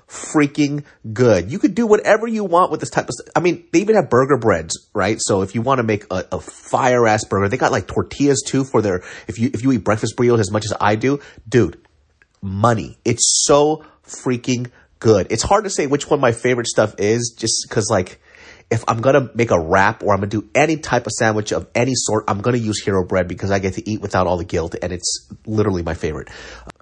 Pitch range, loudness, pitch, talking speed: 105-140 Hz, -18 LUFS, 115 Hz, 240 wpm